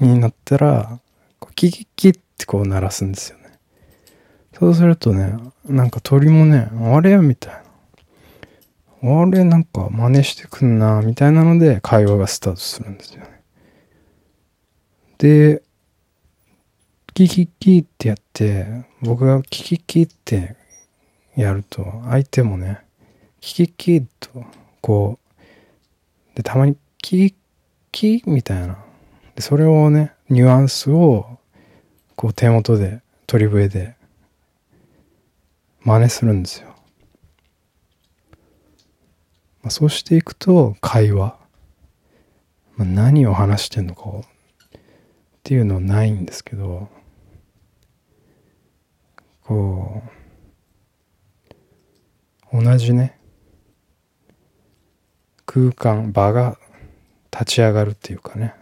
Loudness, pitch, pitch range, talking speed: -16 LUFS, 115 Hz, 100-135 Hz, 200 characters per minute